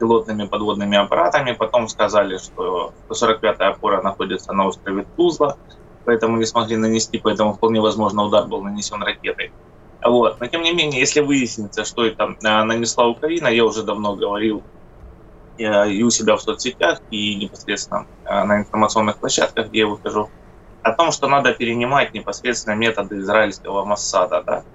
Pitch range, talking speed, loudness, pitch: 105-120 Hz, 150 wpm, -19 LUFS, 110 Hz